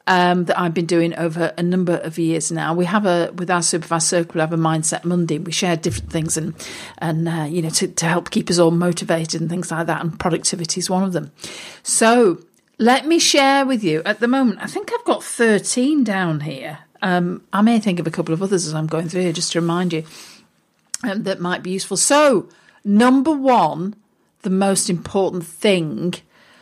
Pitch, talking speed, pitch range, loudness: 180 Hz, 215 wpm, 165-205 Hz, -18 LUFS